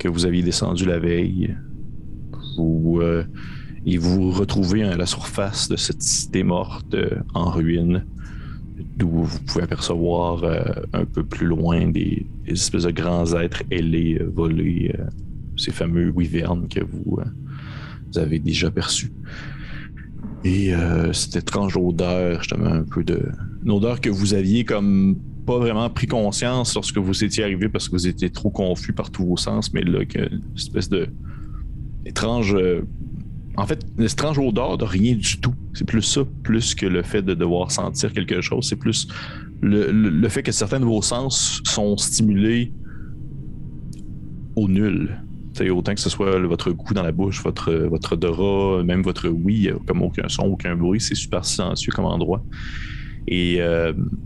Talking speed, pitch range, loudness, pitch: 165 wpm, 85-110 Hz, -21 LUFS, 95 Hz